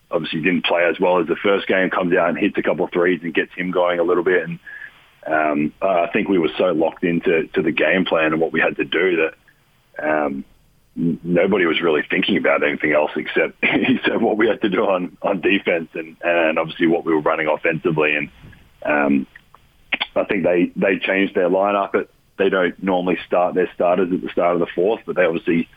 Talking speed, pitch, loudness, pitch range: 225 wpm, 85 Hz, -19 LUFS, 75-90 Hz